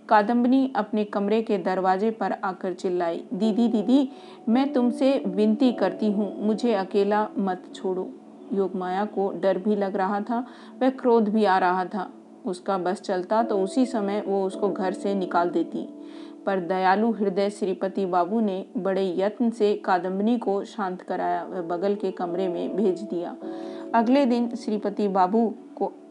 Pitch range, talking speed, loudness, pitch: 190-230 Hz, 160 wpm, -25 LUFS, 205 Hz